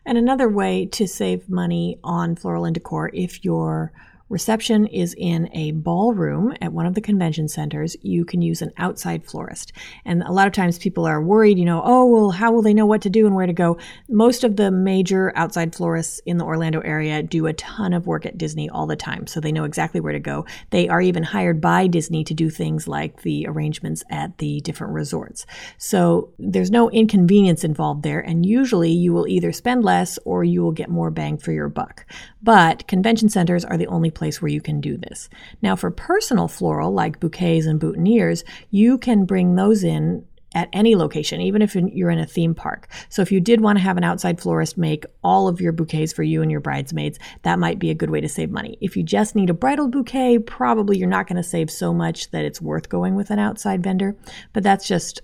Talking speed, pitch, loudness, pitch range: 225 wpm, 175 Hz, -20 LUFS, 160-200 Hz